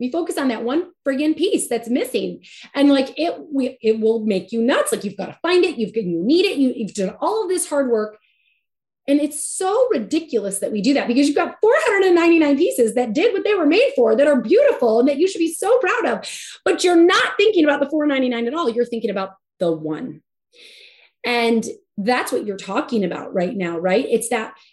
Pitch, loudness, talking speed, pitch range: 275 Hz, -19 LUFS, 225 wpm, 230-350 Hz